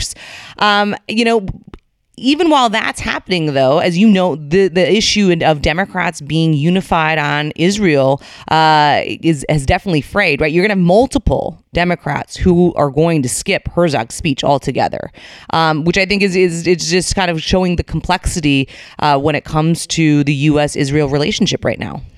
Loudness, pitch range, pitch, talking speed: -14 LUFS, 150-185 Hz, 165 Hz, 175 wpm